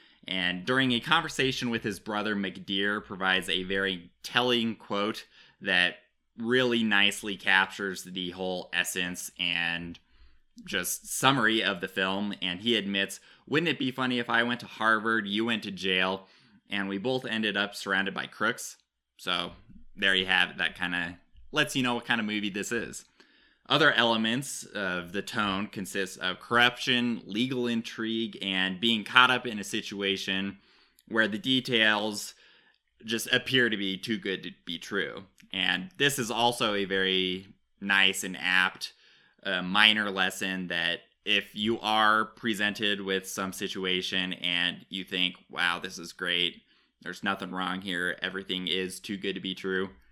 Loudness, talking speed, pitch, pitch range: -28 LUFS, 160 wpm, 100 Hz, 95-115 Hz